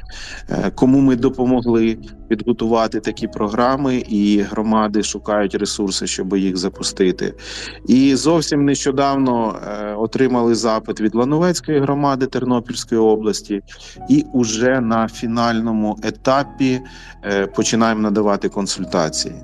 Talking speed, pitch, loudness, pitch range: 95 wpm, 115 Hz, -18 LUFS, 105-130 Hz